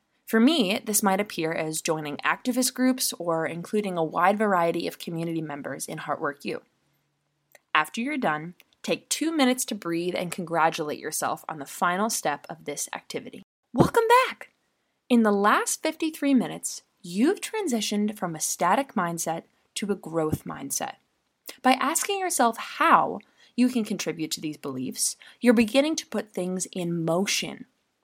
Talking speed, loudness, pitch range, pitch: 155 wpm, -26 LUFS, 165-255 Hz, 205 Hz